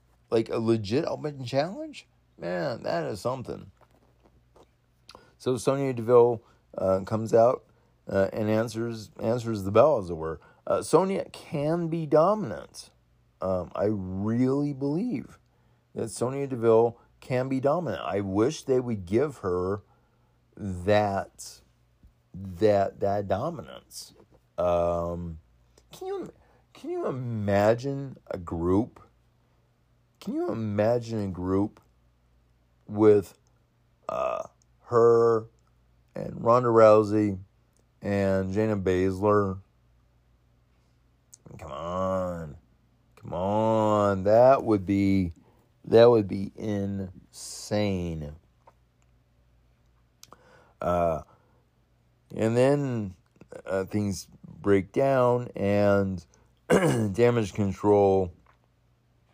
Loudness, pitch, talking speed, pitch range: -26 LUFS, 105 Hz, 95 wpm, 90-115 Hz